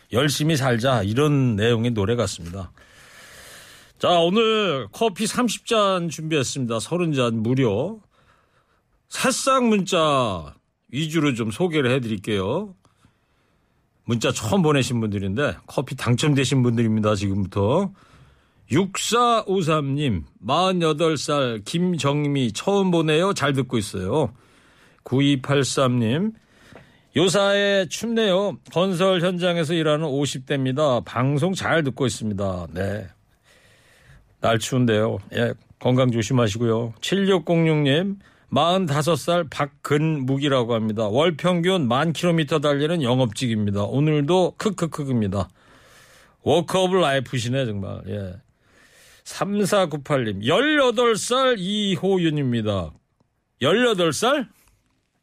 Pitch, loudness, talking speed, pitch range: 145 Hz, -21 LUFS, 210 characters per minute, 120-180 Hz